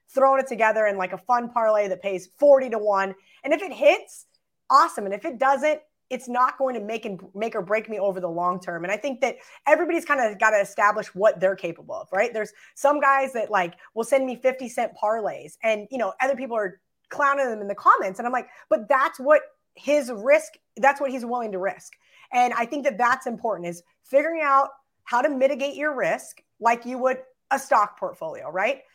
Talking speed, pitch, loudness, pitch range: 225 wpm, 245 Hz, -23 LUFS, 210-280 Hz